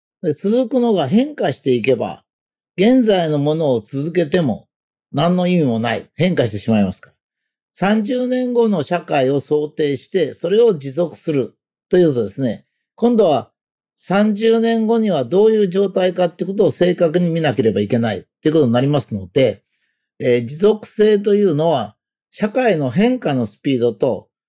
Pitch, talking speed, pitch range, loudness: 175 Hz, 315 characters per minute, 140-215 Hz, -17 LUFS